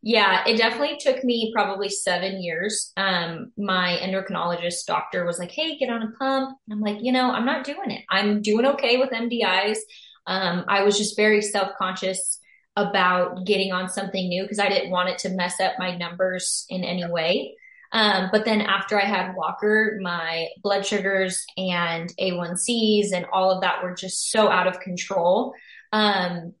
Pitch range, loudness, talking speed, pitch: 180-220 Hz, -23 LUFS, 180 wpm, 195 Hz